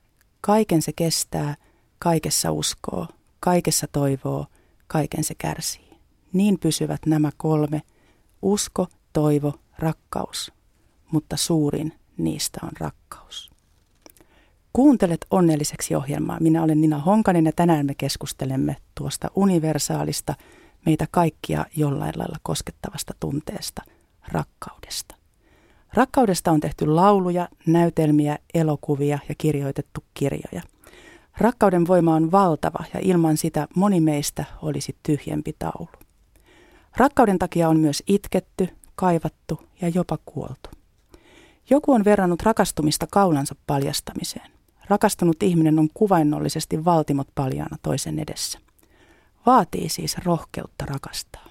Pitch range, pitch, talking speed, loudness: 150-180 Hz, 160 Hz, 105 wpm, -22 LUFS